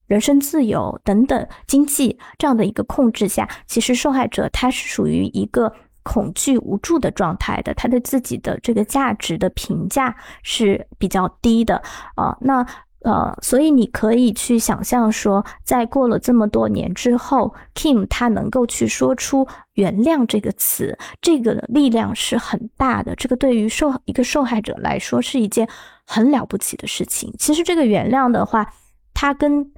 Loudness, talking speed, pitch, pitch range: -18 LUFS, 260 characters per minute, 240 Hz, 215-265 Hz